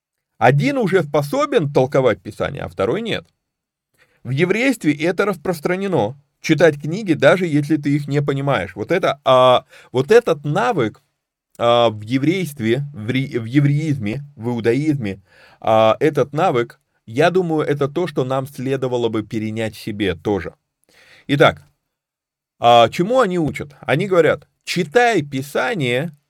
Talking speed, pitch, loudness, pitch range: 130 wpm, 145 Hz, -18 LUFS, 120-170 Hz